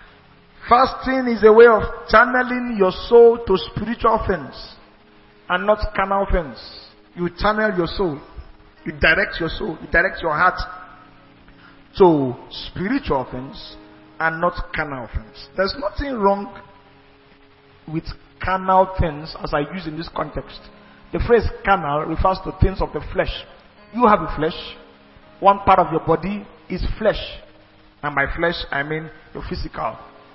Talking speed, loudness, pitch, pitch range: 145 wpm, -19 LUFS, 175 Hz, 140-205 Hz